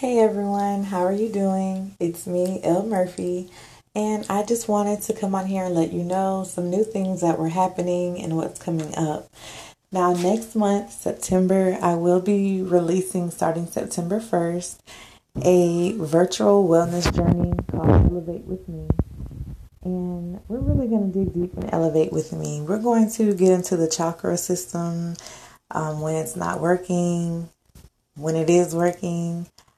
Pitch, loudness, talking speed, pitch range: 180 Hz, -23 LUFS, 160 wpm, 170-195 Hz